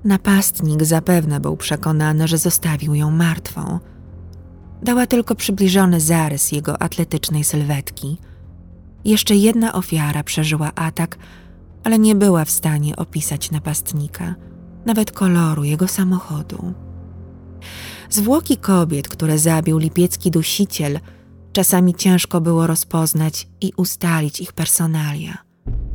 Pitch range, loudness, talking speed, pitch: 150-180 Hz, -17 LUFS, 105 wpm, 160 Hz